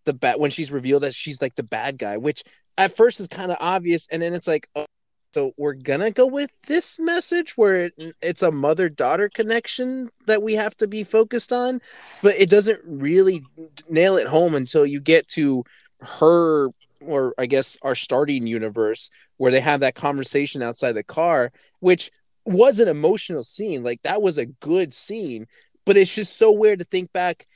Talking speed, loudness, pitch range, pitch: 190 wpm, -20 LUFS, 145-215 Hz, 170 Hz